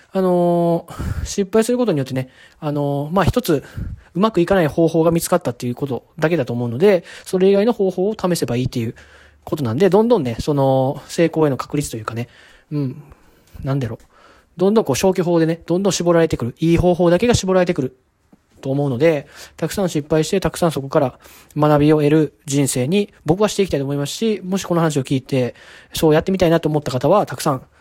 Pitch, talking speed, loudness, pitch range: 160 Hz, 430 characters per minute, -18 LUFS, 140-180 Hz